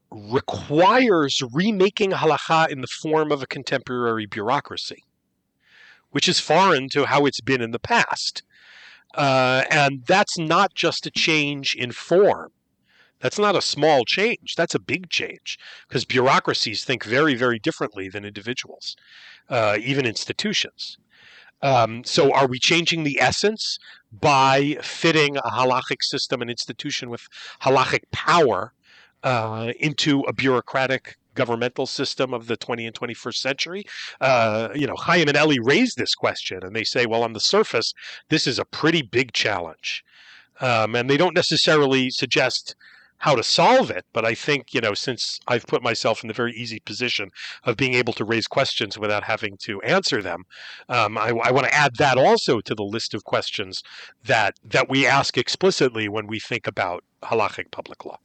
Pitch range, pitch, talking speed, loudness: 115-155 Hz, 130 Hz, 165 wpm, -21 LUFS